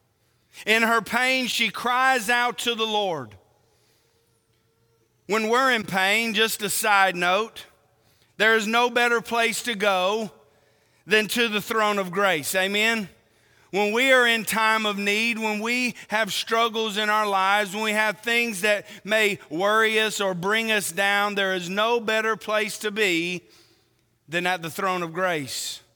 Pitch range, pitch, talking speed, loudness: 175-225 Hz, 210 Hz, 160 wpm, -22 LUFS